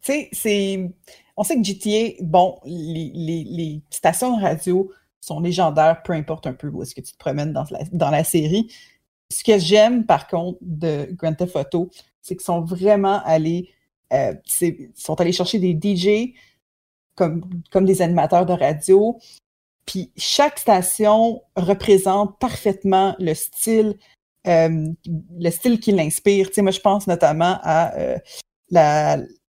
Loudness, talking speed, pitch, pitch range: -19 LUFS, 160 wpm, 180 Hz, 165-205 Hz